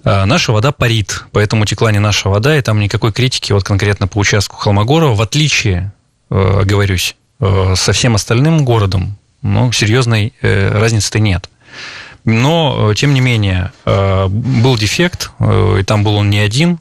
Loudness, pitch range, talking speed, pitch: -12 LUFS, 100-120 Hz, 145 wpm, 110 Hz